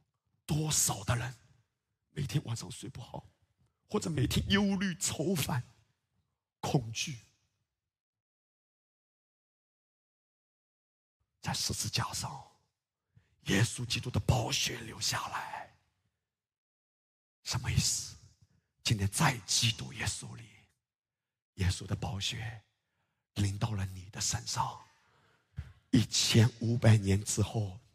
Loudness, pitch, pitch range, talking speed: -32 LUFS, 115 Hz, 105-130 Hz, 145 characters per minute